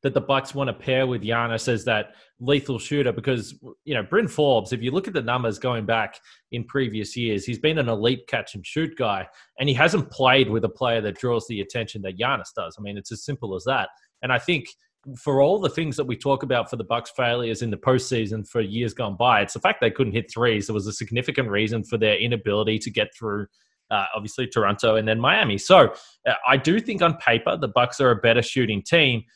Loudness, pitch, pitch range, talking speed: -23 LUFS, 120 Hz, 110-135 Hz, 240 wpm